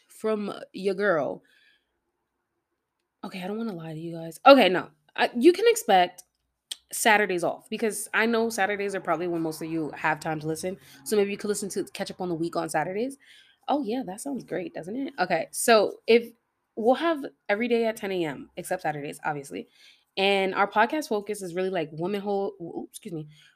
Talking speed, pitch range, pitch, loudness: 195 wpm, 170-225 Hz, 200 Hz, -26 LUFS